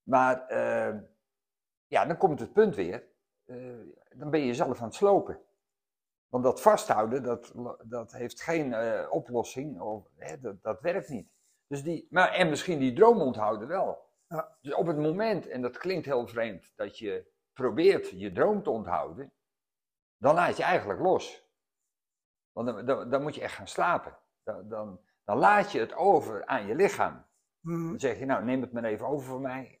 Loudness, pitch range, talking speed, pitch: -29 LUFS, 125-190 Hz, 185 wpm, 140 Hz